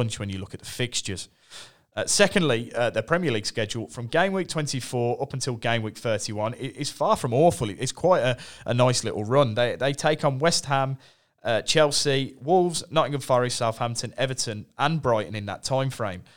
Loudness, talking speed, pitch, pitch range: -25 LUFS, 190 wpm, 130 Hz, 115-145 Hz